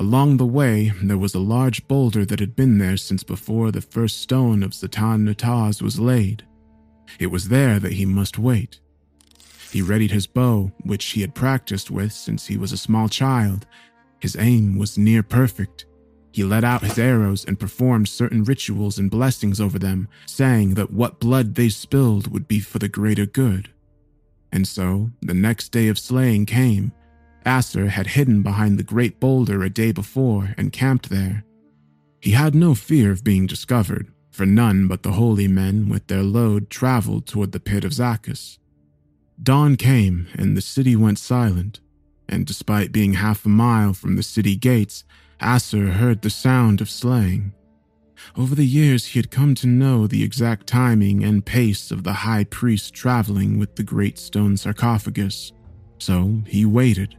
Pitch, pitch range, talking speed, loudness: 105 Hz, 100-120 Hz, 175 wpm, -19 LUFS